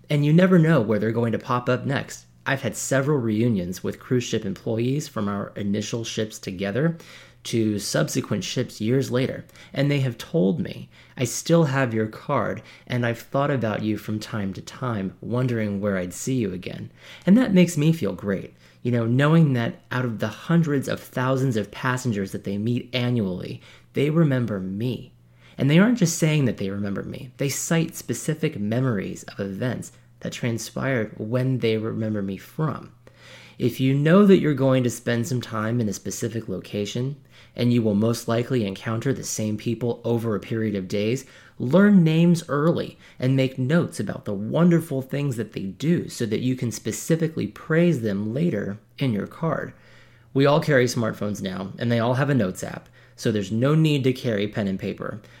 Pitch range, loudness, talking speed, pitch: 110-140 Hz, -23 LUFS, 190 wpm, 120 Hz